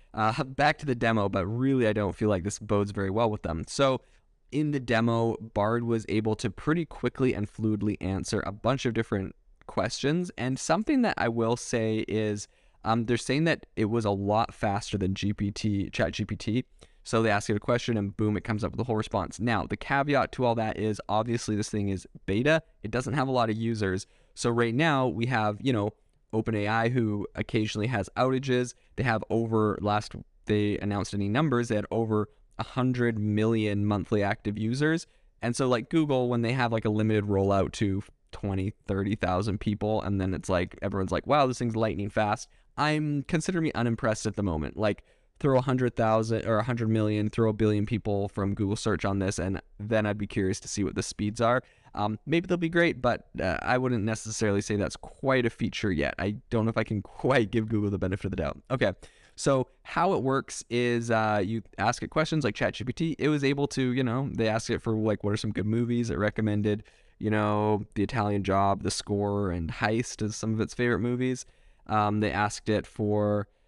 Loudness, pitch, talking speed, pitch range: -28 LUFS, 110 Hz, 210 wpm, 105-120 Hz